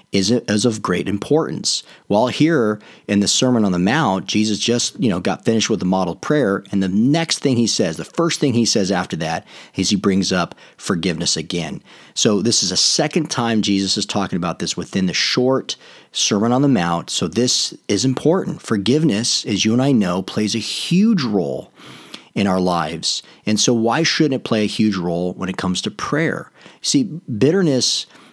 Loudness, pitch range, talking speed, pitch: -18 LUFS, 95-130 Hz, 195 wpm, 110 Hz